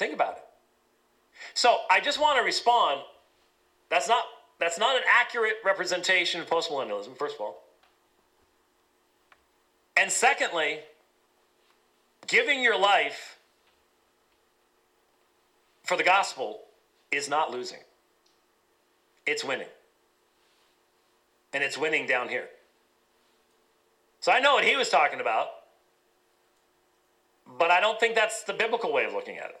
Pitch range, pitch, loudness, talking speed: 160-235 Hz, 195 Hz, -25 LUFS, 120 wpm